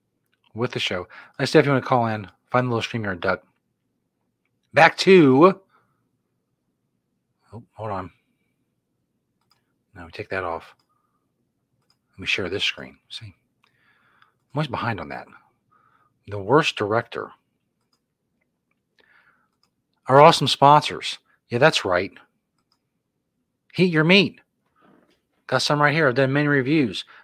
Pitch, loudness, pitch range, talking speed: 135 Hz, -20 LUFS, 115-150 Hz, 125 wpm